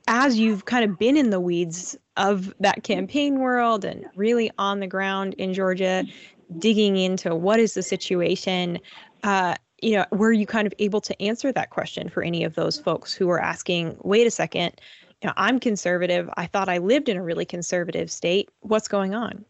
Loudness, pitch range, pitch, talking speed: -23 LUFS, 180-220 Hz, 195 Hz, 195 wpm